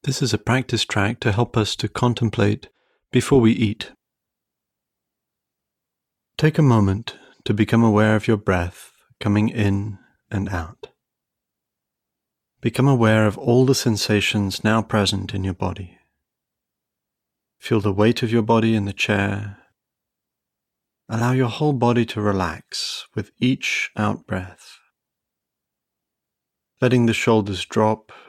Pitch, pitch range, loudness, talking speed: 110 Hz, 100-120 Hz, -20 LUFS, 125 wpm